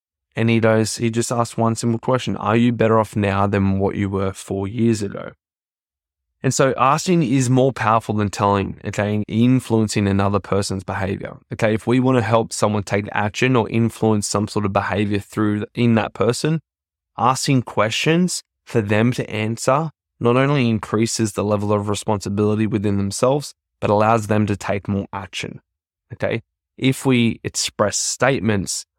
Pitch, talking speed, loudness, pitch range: 110 Hz, 165 wpm, -19 LUFS, 100-120 Hz